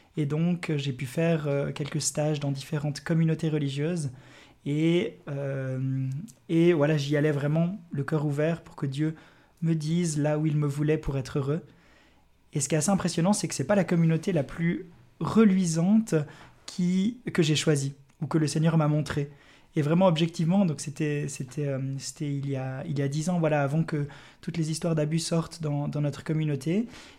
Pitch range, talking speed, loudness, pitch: 145-165 Hz, 190 wpm, -27 LUFS, 155 Hz